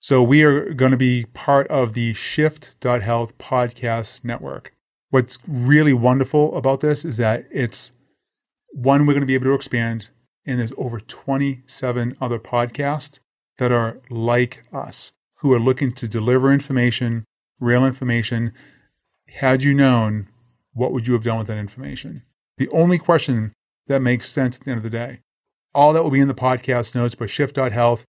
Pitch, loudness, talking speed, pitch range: 125 Hz, -19 LUFS, 170 wpm, 120-140 Hz